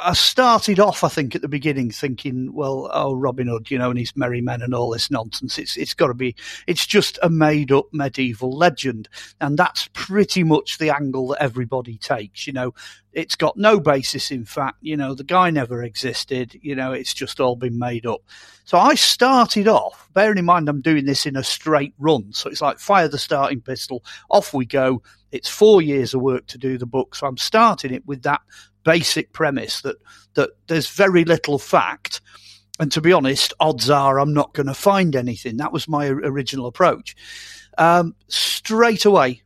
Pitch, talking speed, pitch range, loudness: 140 Hz, 200 wpm, 130-170 Hz, -19 LUFS